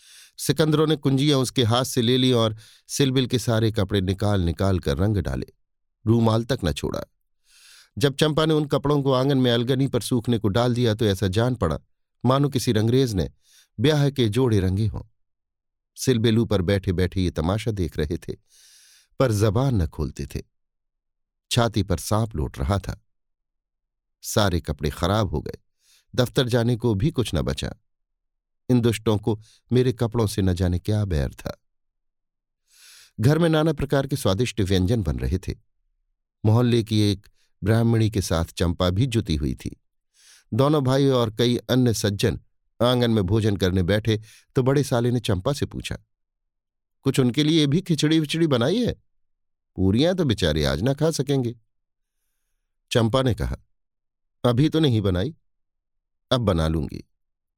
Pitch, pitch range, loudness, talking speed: 110 Hz, 95-125 Hz, -23 LUFS, 160 wpm